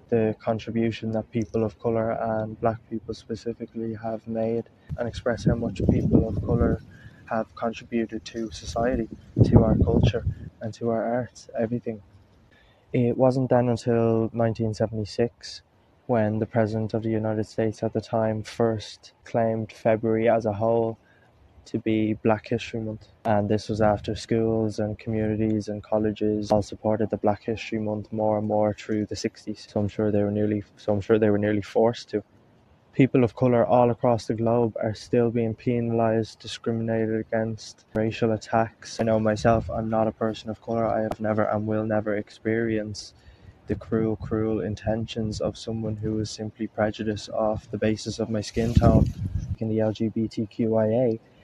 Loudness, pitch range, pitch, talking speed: -26 LUFS, 105-115 Hz, 110 Hz, 165 wpm